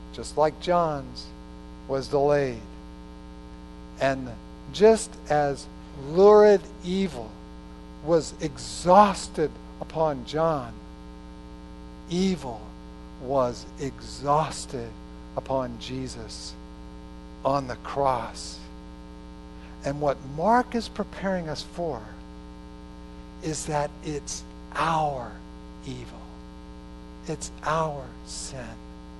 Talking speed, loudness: 75 wpm, -26 LUFS